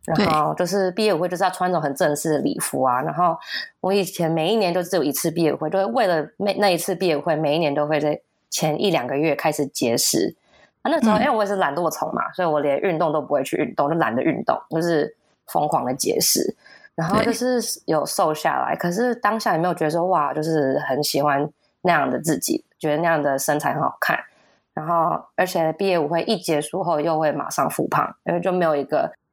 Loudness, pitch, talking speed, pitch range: -21 LUFS, 170 Hz, 335 characters per minute, 155-195 Hz